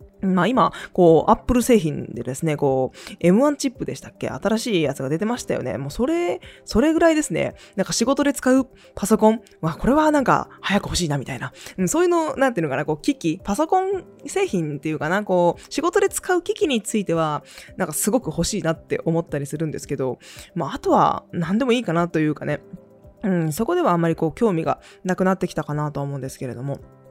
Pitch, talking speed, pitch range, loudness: 185 Hz, 385 characters per minute, 155-245 Hz, -21 LUFS